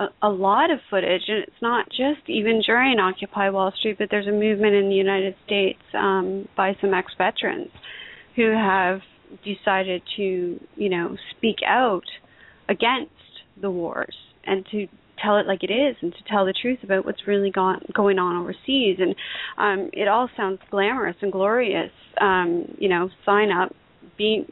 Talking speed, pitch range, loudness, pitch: 170 wpm, 190-215 Hz, -22 LUFS, 200 Hz